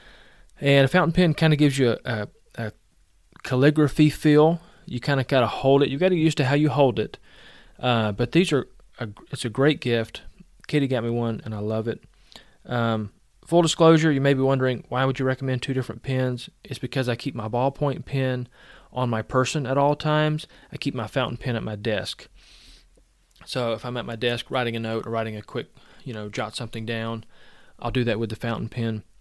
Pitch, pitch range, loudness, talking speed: 125 Hz, 115-140 Hz, -23 LUFS, 215 wpm